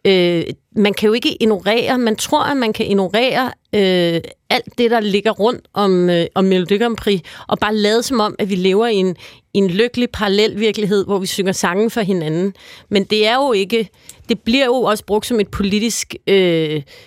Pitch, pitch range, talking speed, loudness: 210 Hz, 195-230 Hz, 205 wpm, -16 LUFS